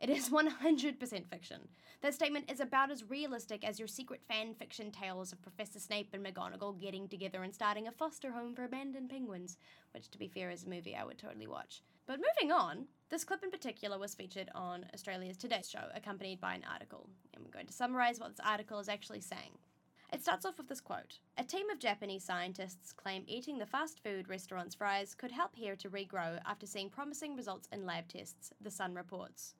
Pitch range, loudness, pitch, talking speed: 190-265 Hz, -41 LUFS, 210 Hz, 210 wpm